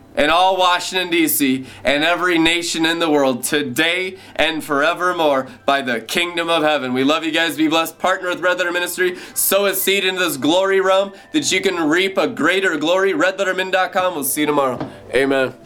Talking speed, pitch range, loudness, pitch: 190 wpm, 150-190 Hz, -17 LUFS, 175 Hz